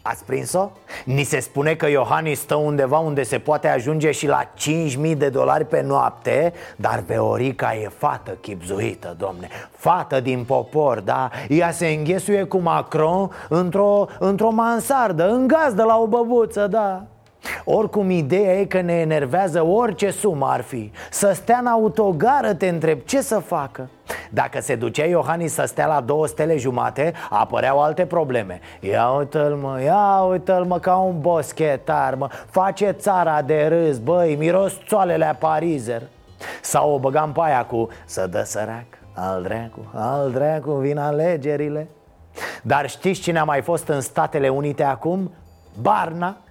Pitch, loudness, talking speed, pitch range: 155 Hz, -20 LUFS, 155 wpm, 140-185 Hz